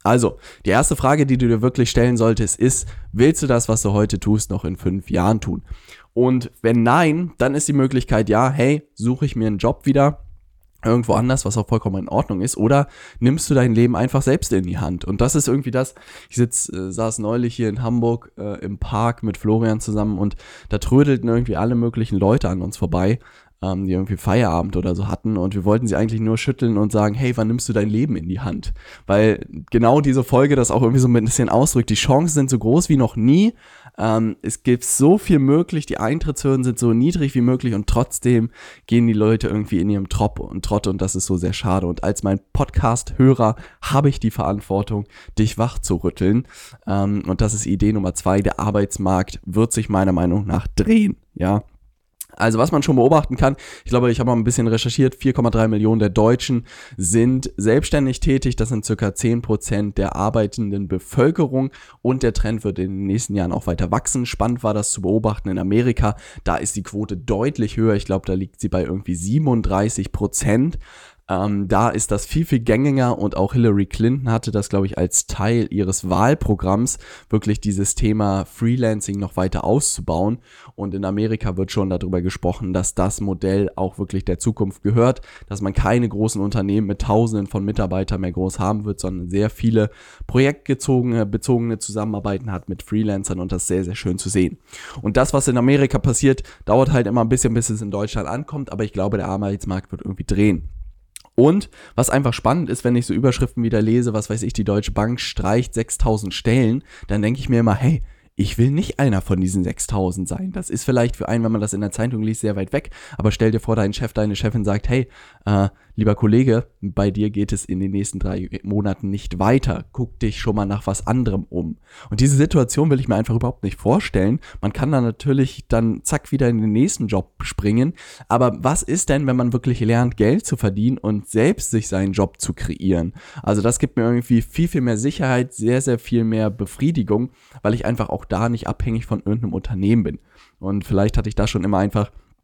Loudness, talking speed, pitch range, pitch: -19 LUFS, 210 wpm, 100-125 Hz, 110 Hz